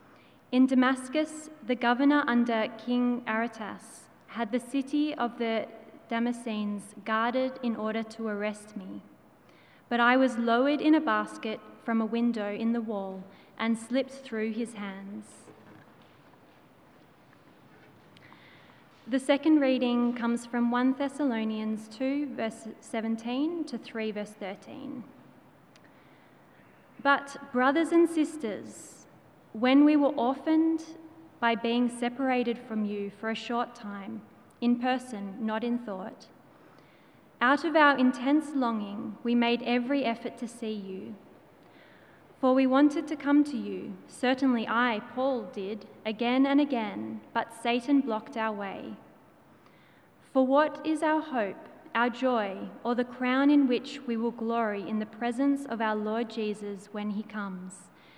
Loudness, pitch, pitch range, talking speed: -29 LUFS, 240 Hz, 220-270 Hz, 135 wpm